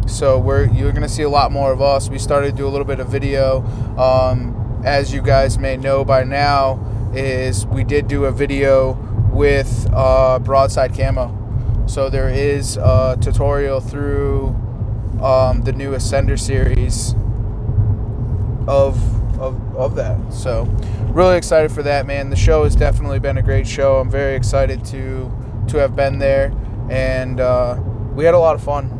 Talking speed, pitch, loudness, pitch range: 170 wpm, 120 Hz, -17 LUFS, 110-135 Hz